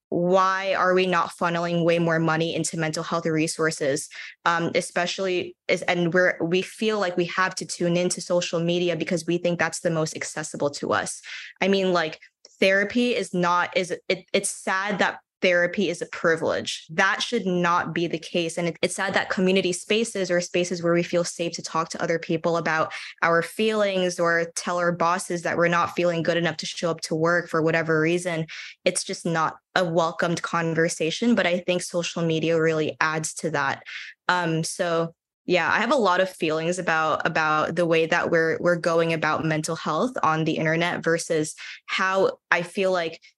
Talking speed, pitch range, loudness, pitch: 190 wpm, 165-185 Hz, -24 LUFS, 175 Hz